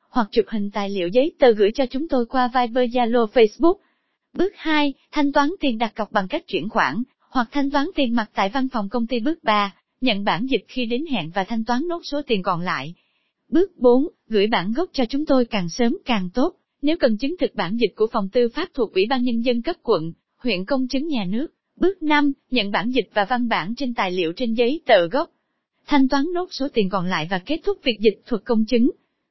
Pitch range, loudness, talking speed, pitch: 220-285 Hz, -21 LUFS, 240 wpm, 245 Hz